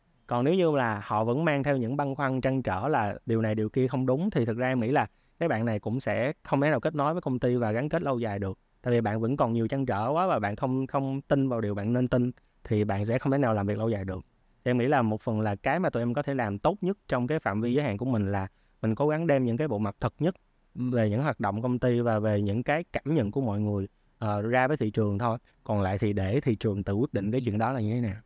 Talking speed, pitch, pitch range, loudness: 310 wpm, 120 Hz, 110-140 Hz, -28 LUFS